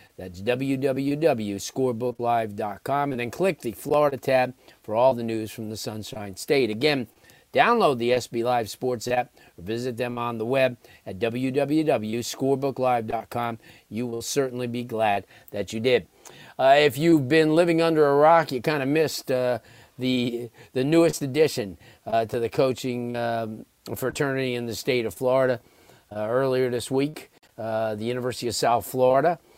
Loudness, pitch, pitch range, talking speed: -24 LUFS, 125 Hz, 115-135 Hz, 155 wpm